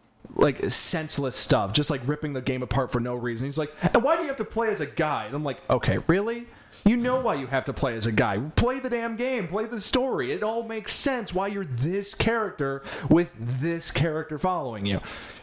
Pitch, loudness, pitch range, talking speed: 160 Hz, -26 LUFS, 135-220 Hz, 230 wpm